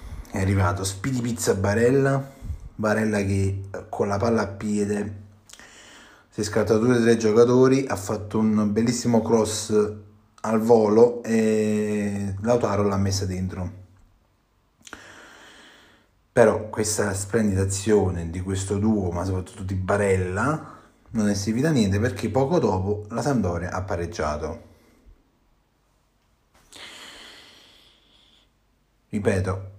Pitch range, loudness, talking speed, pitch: 95-110 Hz, -23 LUFS, 110 wpm, 105 Hz